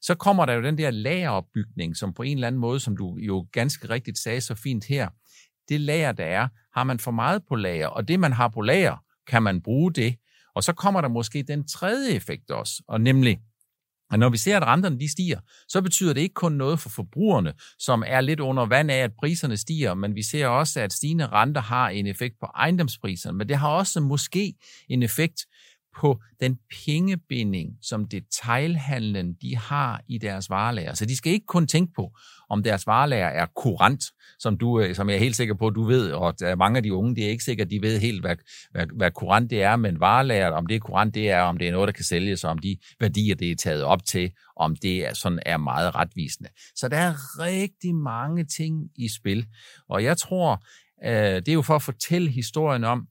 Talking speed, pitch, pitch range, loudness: 220 wpm, 120 Hz, 105-150 Hz, -24 LUFS